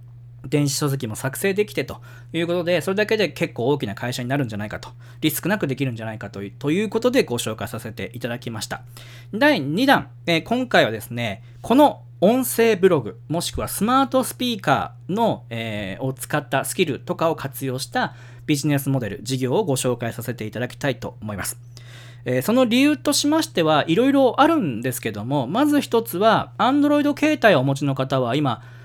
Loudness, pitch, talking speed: -21 LUFS, 135 Hz, 405 characters per minute